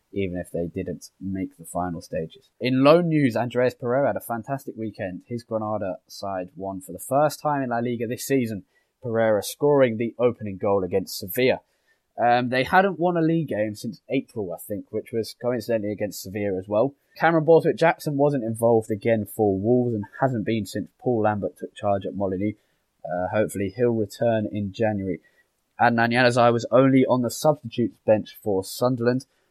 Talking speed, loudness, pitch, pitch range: 180 wpm, -24 LUFS, 115 Hz, 105-130 Hz